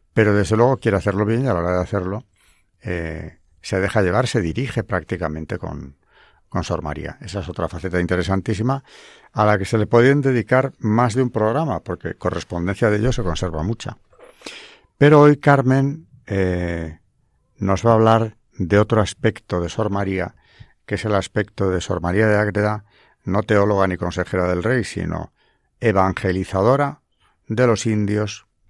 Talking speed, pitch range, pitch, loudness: 165 wpm, 90-115 Hz, 105 Hz, -20 LUFS